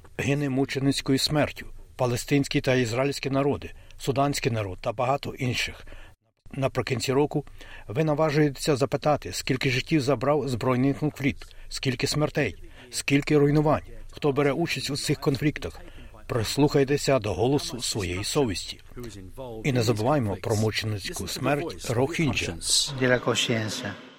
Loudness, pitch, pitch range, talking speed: -26 LUFS, 130 Hz, 110-145 Hz, 110 wpm